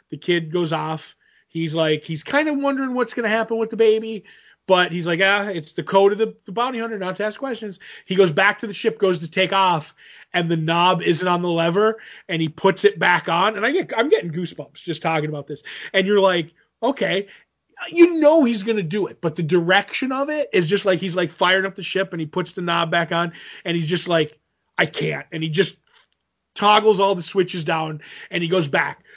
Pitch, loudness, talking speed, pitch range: 190 Hz, -20 LUFS, 240 wpm, 170-215 Hz